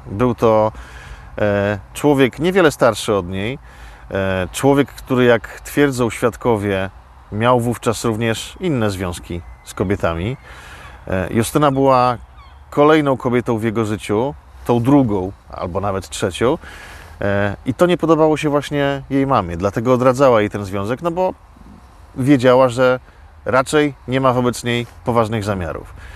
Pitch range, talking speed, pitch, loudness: 95-135 Hz, 135 wpm, 120 Hz, -17 LUFS